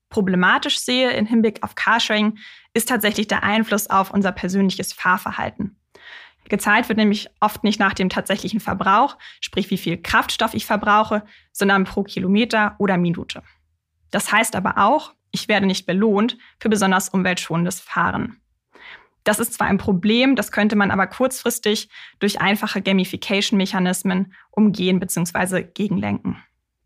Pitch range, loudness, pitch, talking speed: 190-215 Hz, -19 LUFS, 200 Hz, 140 wpm